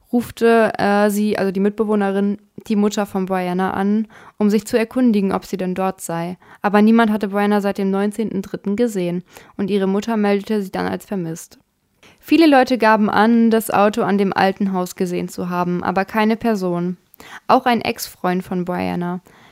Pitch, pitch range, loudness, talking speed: 205 Hz, 190-220 Hz, -18 LUFS, 175 wpm